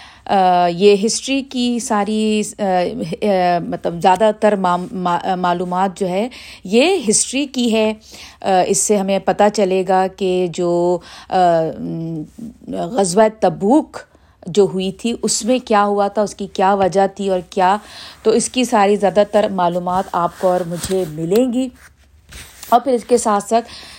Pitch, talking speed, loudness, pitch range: 200 Hz, 145 wpm, -16 LUFS, 180-220 Hz